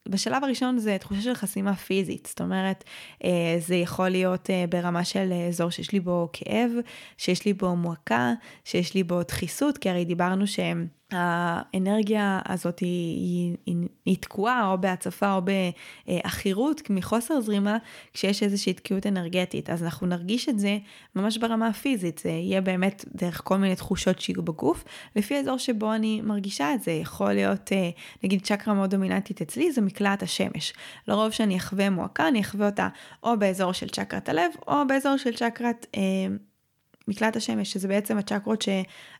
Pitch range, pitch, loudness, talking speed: 180-215 Hz, 195 Hz, -27 LUFS, 160 wpm